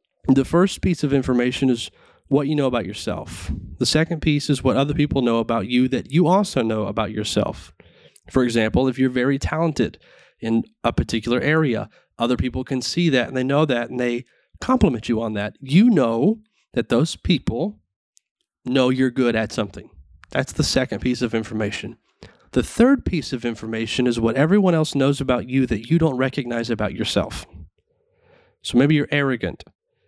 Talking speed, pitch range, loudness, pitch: 180 wpm, 115-150 Hz, -21 LUFS, 130 Hz